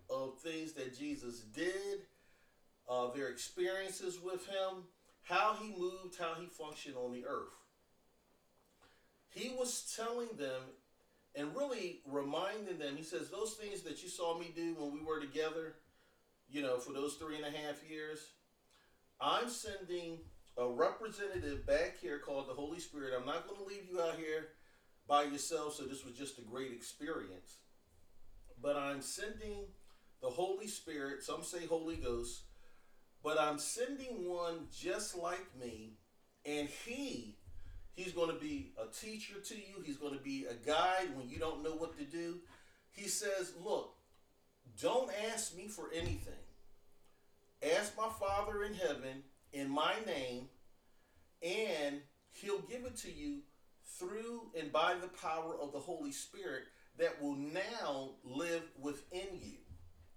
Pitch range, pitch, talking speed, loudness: 140-195 Hz, 160 Hz, 155 wpm, -41 LUFS